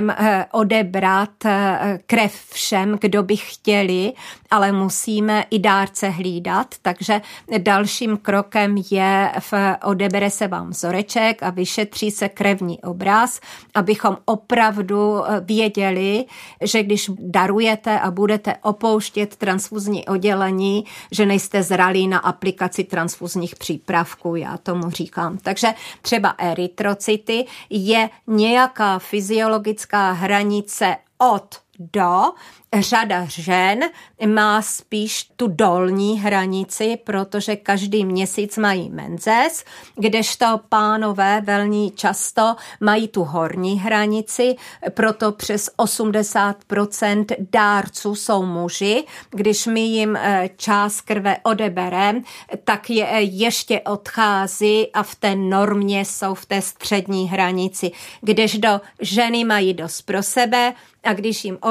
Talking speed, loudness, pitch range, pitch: 110 wpm, -19 LUFS, 195-215 Hz, 205 Hz